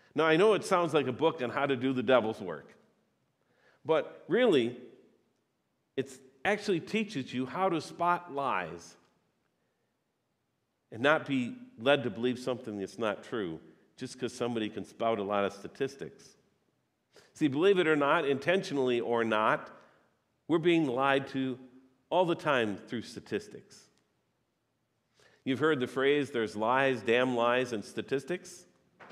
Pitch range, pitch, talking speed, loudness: 120-170 Hz, 135 Hz, 145 wpm, -30 LUFS